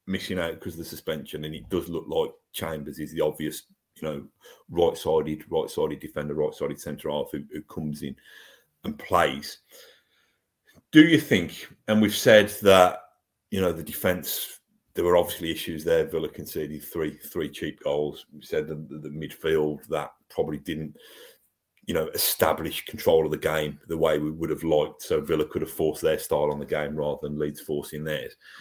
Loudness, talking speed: -26 LUFS, 180 wpm